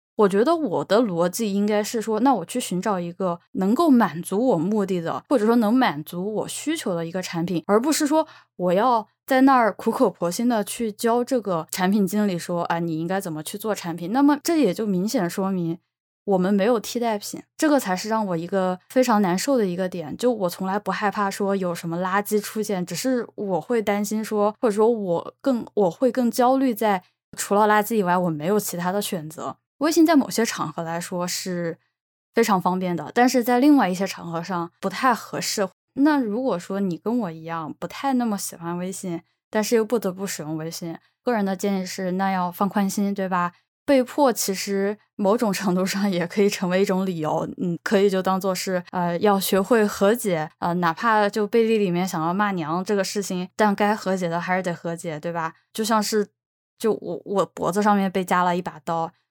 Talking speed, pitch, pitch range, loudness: 300 characters per minute, 200 Hz, 180-225 Hz, -23 LUFS